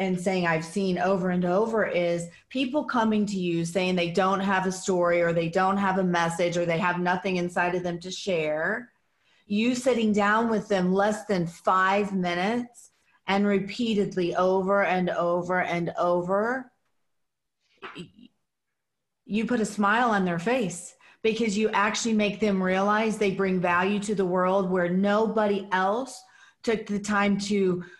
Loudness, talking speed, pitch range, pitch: -25 LUFS, 160 wpm, 180-210 Hz, 195 Hz